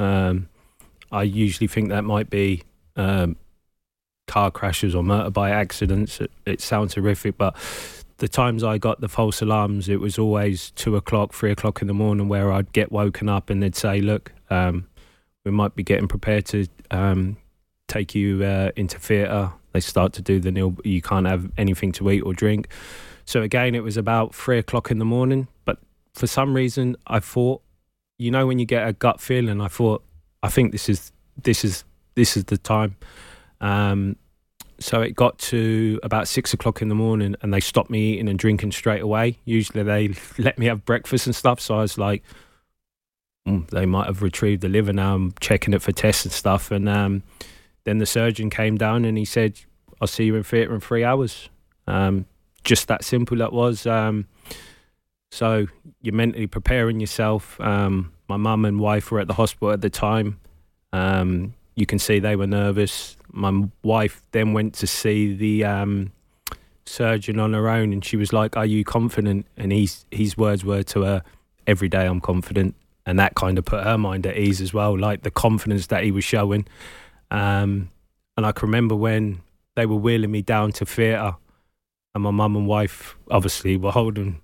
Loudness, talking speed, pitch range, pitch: -22 LUFS, 195 wpm, 95-110 Hz, 105 Hz